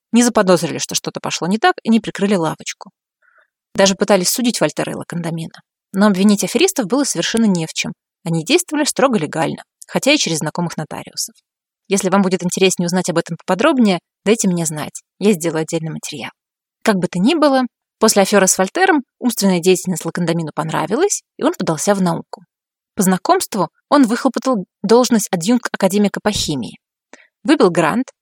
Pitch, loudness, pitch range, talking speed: 195 Hz, -16 LUFS, 175-240 Hz, 165 wpm